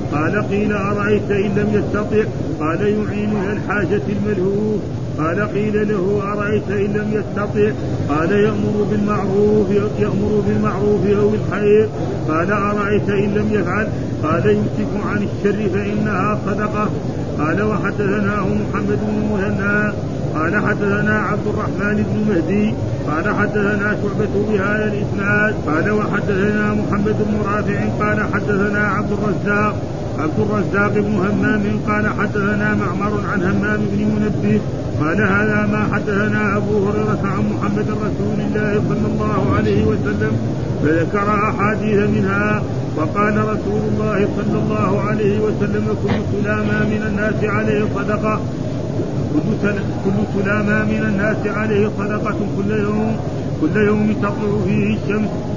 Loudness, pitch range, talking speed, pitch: -18 LUFS, 135-205 Hz, 125 wpm, 195 Hz